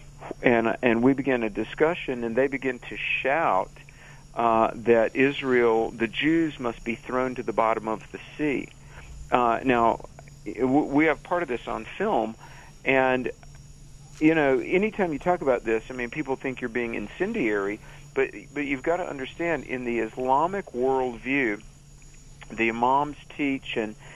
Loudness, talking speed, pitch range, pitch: -25 LUFS, 160 wpm, 115-145 Hz, 130 Hz